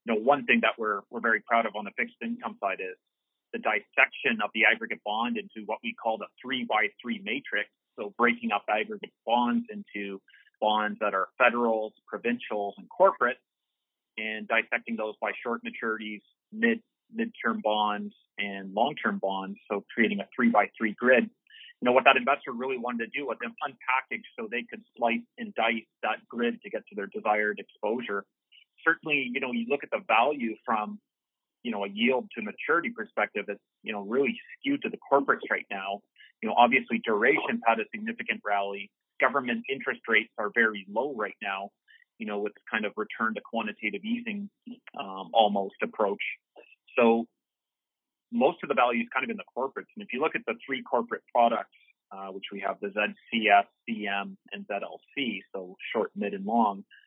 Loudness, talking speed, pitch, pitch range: -28 LUFS, 185 wpm, 115 Hz, 105-155 Hz